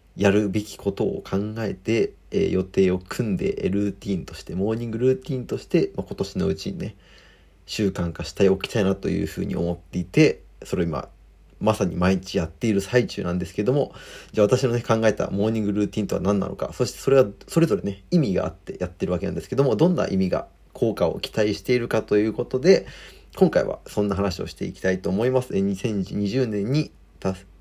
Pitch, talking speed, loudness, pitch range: 100 Hz, 435 characters per minute, -24 LUFS, 95-115 Hz